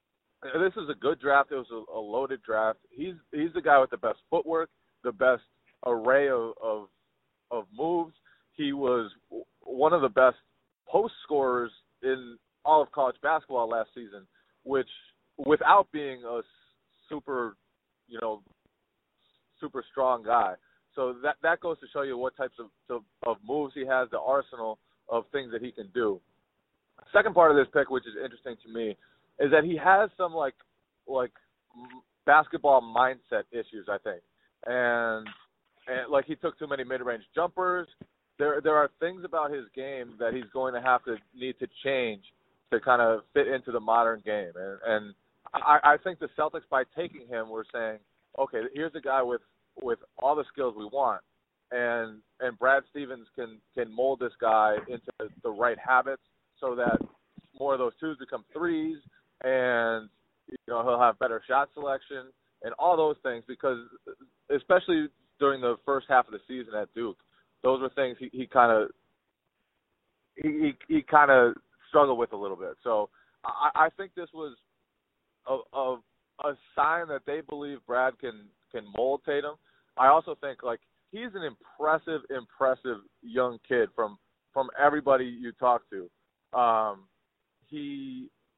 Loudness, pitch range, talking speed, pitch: -28 LUFS, 120-160 Hz, 170 wpm, 135 Hz